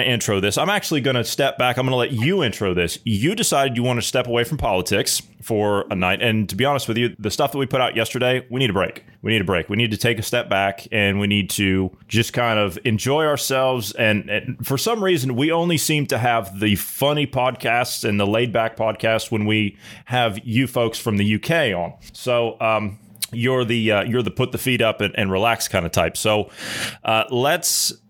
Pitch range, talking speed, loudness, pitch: 105-130 Hz, 235 wpm, -20 LUFS, 115 Hz